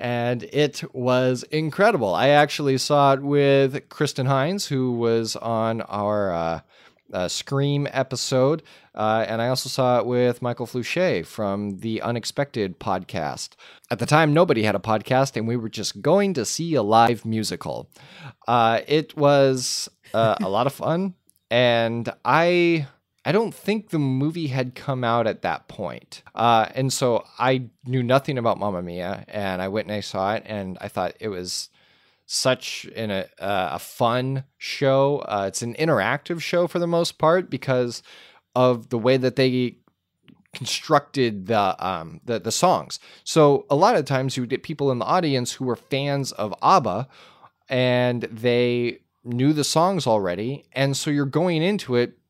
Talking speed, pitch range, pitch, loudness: 170 wpm, 115-145 Hz, 130 Hz, -22 LUFS